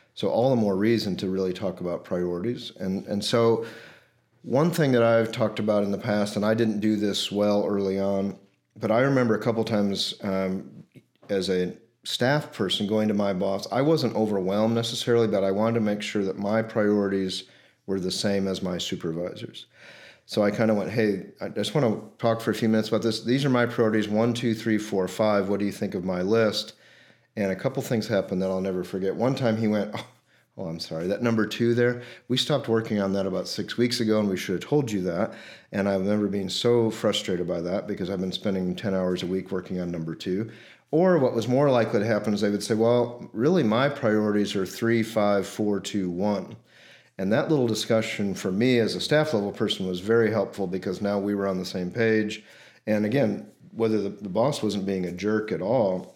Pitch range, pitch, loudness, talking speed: 95-115 Hz, 105 Hz, -25 LUFS, 225 wpm